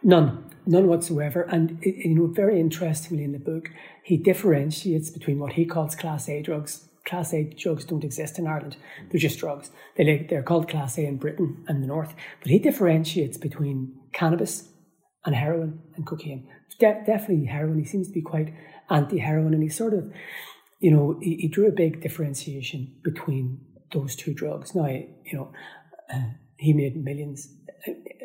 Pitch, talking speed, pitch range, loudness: 160 Hz, 170 wpm, 150-170 Hz, -25 LUFS